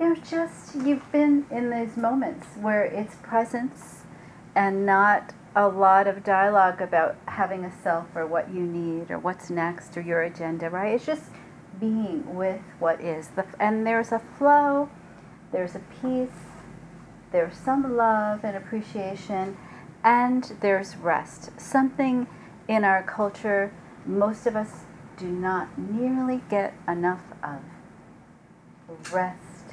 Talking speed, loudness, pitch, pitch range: 135 wpm, -25 LUFS, 200 Hz, 180-235 Hz